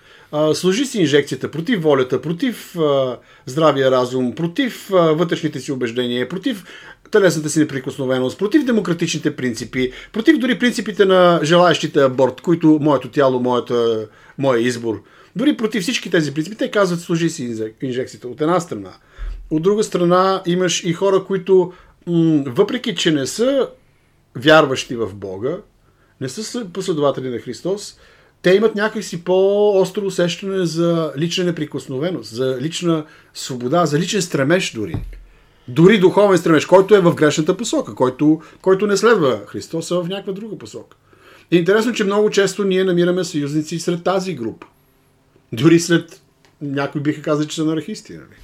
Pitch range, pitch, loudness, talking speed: 140-190 Hz, 170 Hz, -17 LUFS, 150 wpm